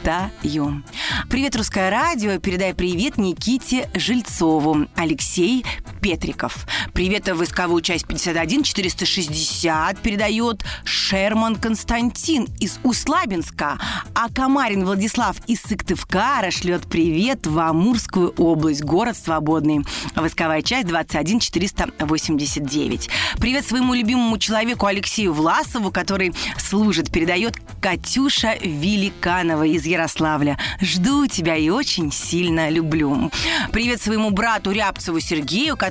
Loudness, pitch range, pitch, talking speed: -19 LUFS, 165-225 Hz, 185 Hz, 95 wpm